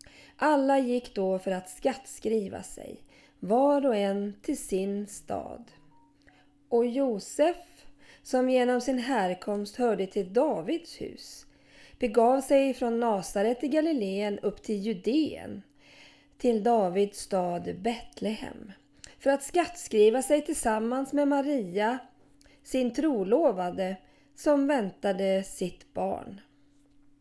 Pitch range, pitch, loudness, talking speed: 200-275 Hz, 235 Hz, -28 LUFS, 110 wpm